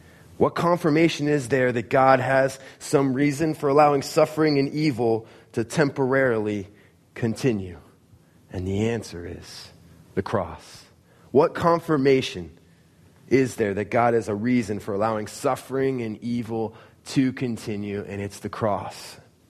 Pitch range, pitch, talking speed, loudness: 105-140 Hz, 120 Hz, 130 wpm, -23 LUFS